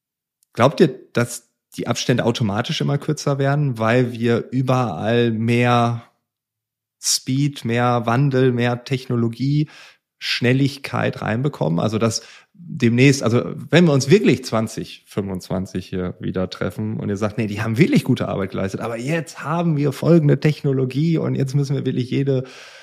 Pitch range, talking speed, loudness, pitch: 115-140 Hz, 140 wpm, -20 LUFS, 125 Hz